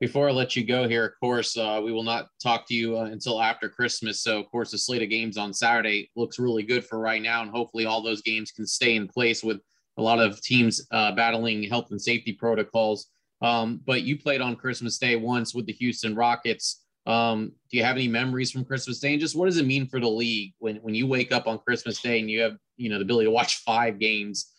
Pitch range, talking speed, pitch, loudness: 110-125 Hz, 250 wpm, 115 Hz, -25 LUFS